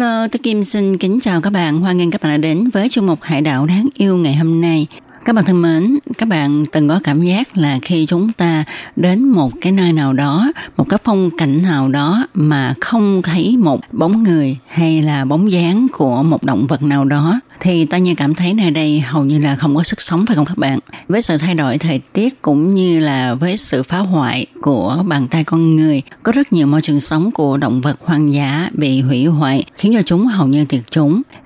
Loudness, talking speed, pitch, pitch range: -14 LUFS, 235 wpm, 165 Hz, 150-195 Hz